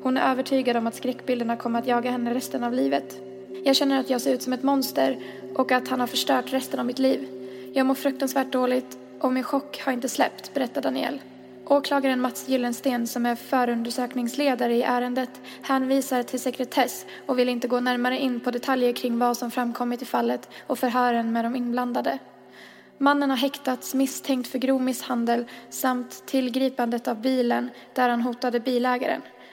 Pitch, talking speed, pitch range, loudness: 250 Hz, 180 wpm, 240-265 Hz, -25 LUFS